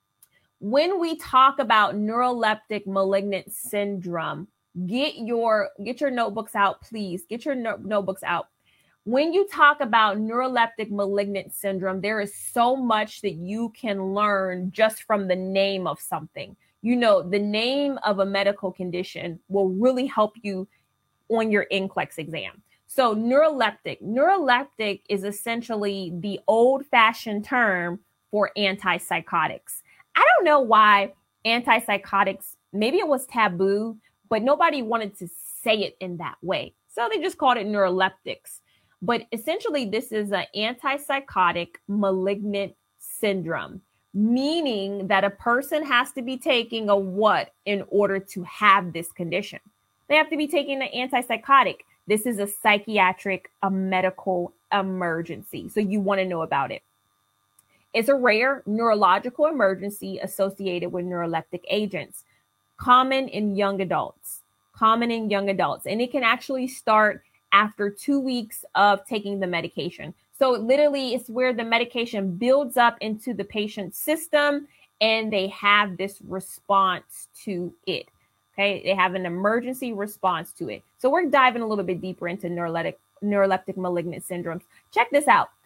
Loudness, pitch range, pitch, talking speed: -23 LUFS, 190-235 Hz, 205 Hz, 145 wpm